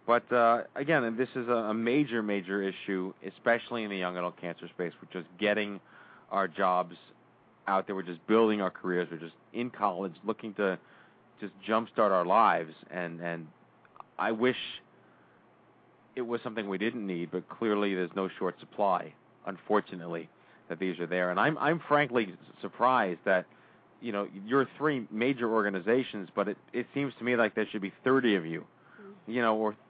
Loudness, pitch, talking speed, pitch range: -31 LUFS, 105 Hz, 175 wpm, 90-120 Hz